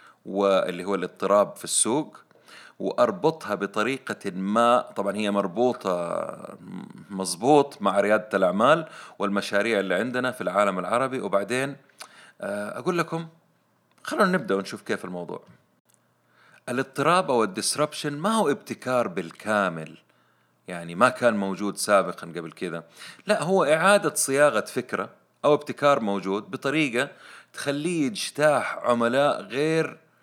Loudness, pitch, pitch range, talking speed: -24 LUFS, 130 Hz, 100-155 Hz, 110 wpm